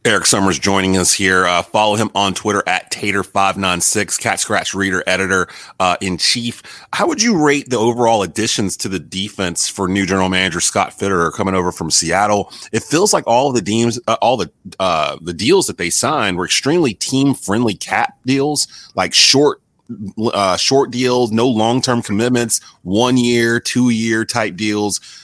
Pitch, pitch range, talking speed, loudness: 105 Hz, 95-120 Hz, 190 wpm, -15 LUFS